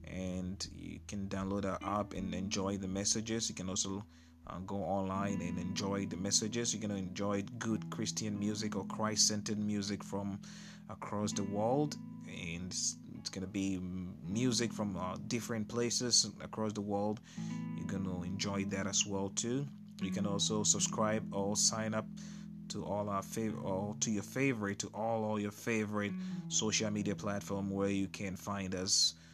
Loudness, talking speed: -36 LUFS, 165 wpm